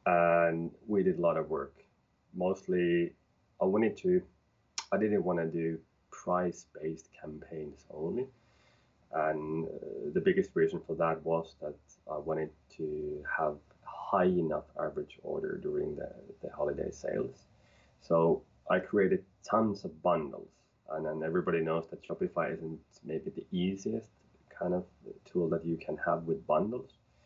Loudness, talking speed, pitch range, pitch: -33 LUFS, 145 wpm, 80-90 Hz, 85 Hz